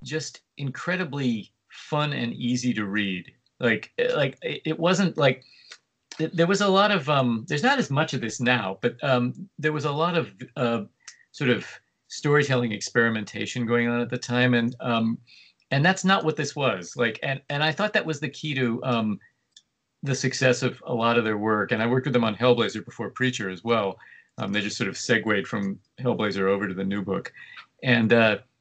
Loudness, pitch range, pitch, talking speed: -25 LUFS, 115-150 Hz, 125 Hz, 200 wpm